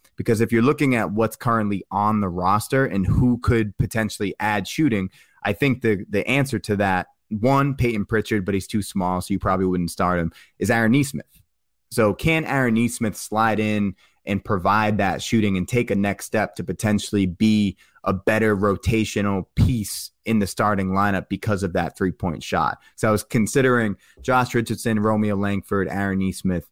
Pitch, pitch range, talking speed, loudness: 105 Hz, 95-115 Hz, 180 wpm, -22 LUFS